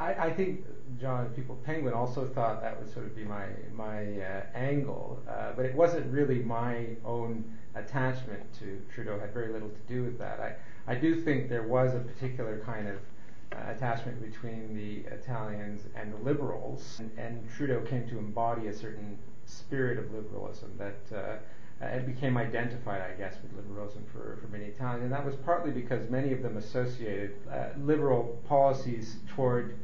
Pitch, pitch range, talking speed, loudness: 115 Hz, 110-130 Hz, 175 wpm, -34 LUFS